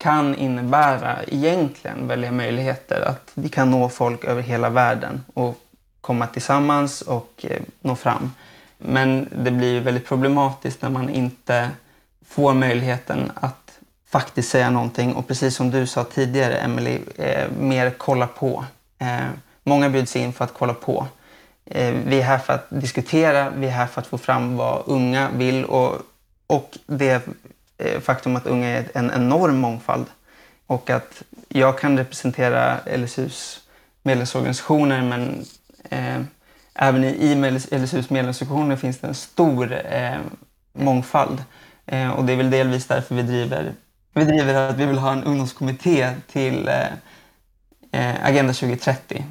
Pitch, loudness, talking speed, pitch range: 130 Hz, -21 LUFS, 145 wpm, 125-135 Hz